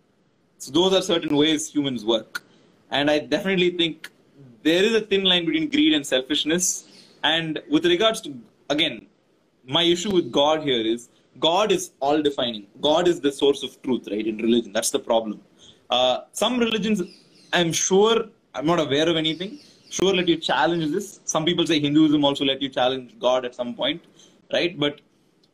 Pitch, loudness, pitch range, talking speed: 155 Hz, -22 LUFS, 140-185 Hz, 175 wpm